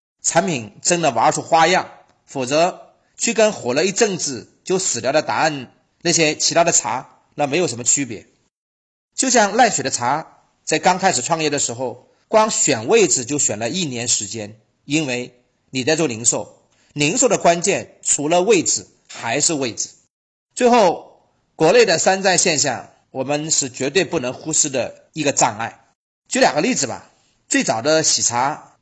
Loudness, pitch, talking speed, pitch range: -18 LUFS, 155 Hz, 240 characters per minute, 125-180 Hz